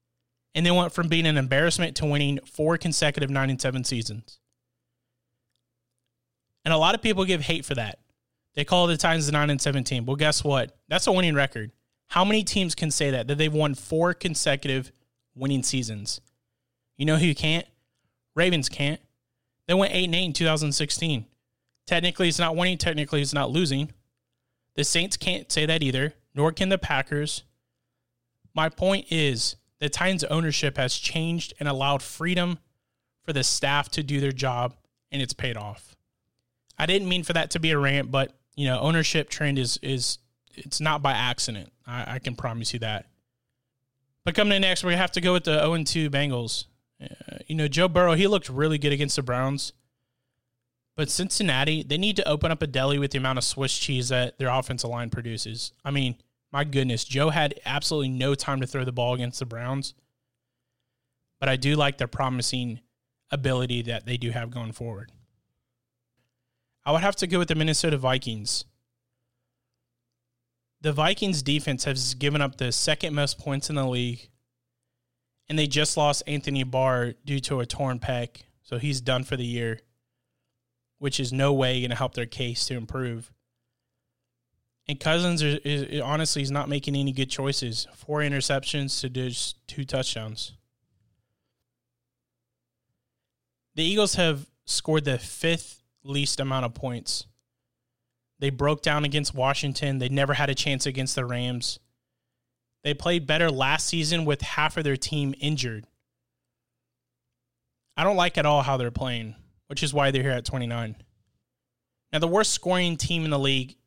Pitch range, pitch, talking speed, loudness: 125-150 Hz, 135 Hz, 175 wpm, -25 LUFS